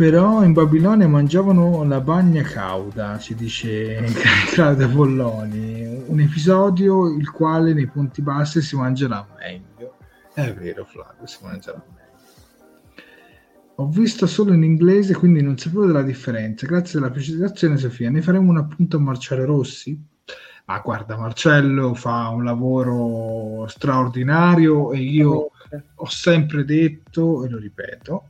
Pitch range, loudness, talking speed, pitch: 120-165 Hz, -18 LUFS, 135 wpm, 145 Hz